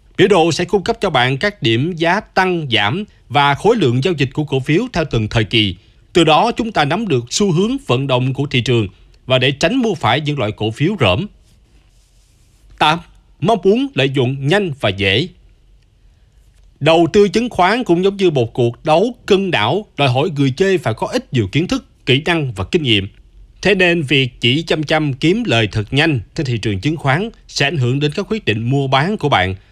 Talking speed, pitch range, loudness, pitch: 220 wpm, 120-180 Hz, -15 LUFS, 145 Hz